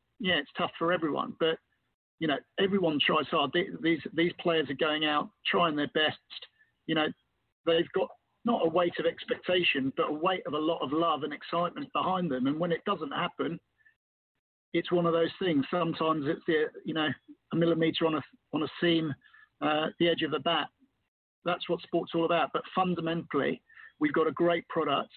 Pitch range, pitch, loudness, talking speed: 160-180 Hz, 170 Hz, -30 LUFS, 195 wpm